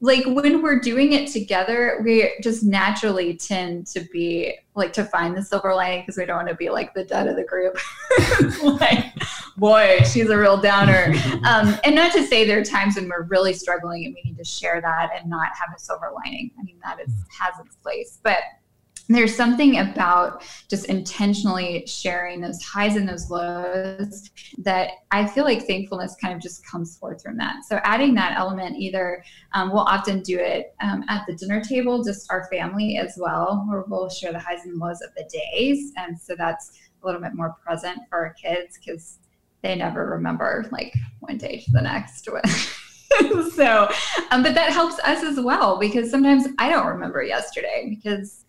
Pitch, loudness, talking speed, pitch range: 195 Hz, -21 LUFS, 195 wpm, 175-235 Hz